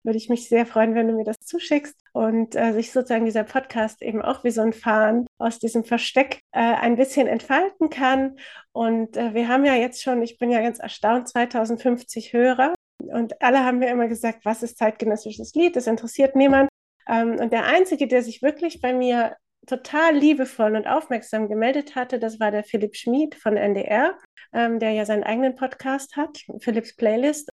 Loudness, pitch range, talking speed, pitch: -22 LUFS, 225-265 Hz, 190 wpm, 235 Hz